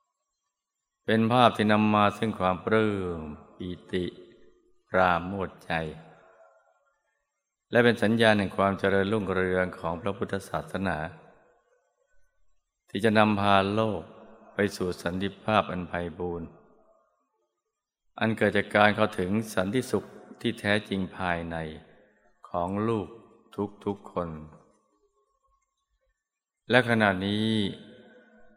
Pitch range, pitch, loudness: 90-110 Hz, 100 Hz, -27 LUFS